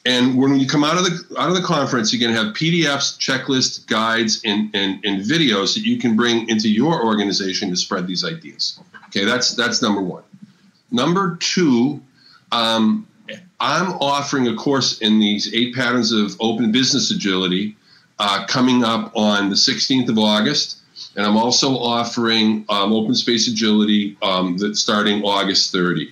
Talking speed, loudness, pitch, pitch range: 170 wpm, -17 LUFS, 115 Hz, 105-140 Hz